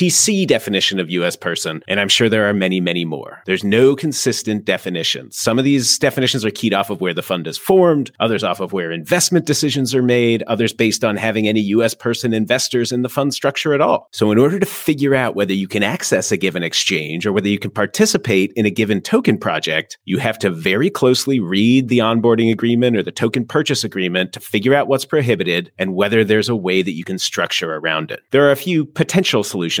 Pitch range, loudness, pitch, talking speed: 100-135 Hz, -16 LUFS, 115 Hz, 225 wpm